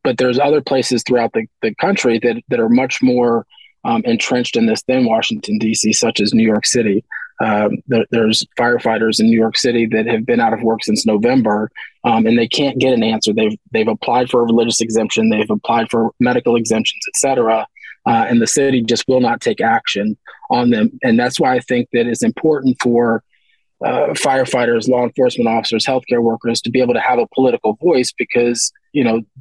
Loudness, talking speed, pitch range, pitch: -15 LUFS, 205 wpm, 115-140 Hz, 120 Hz